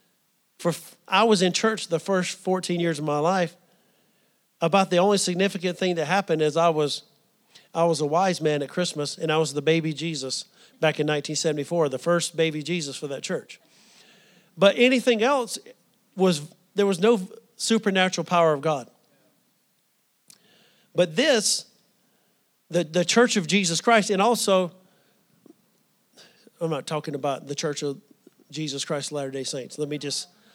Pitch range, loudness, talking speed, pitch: 155-205 Hz, -24 LUFS, 160 wpm, 175 Hz